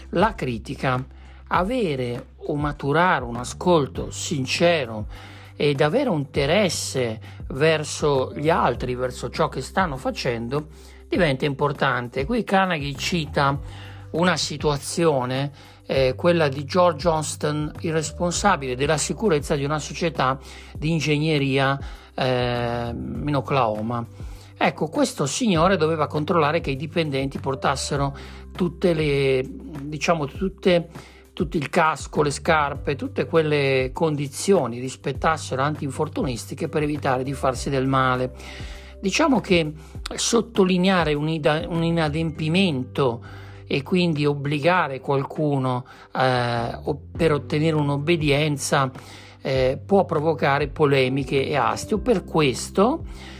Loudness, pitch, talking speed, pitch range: -23 LUFS, 145 Hz, 105 wpm, 125-165 Hz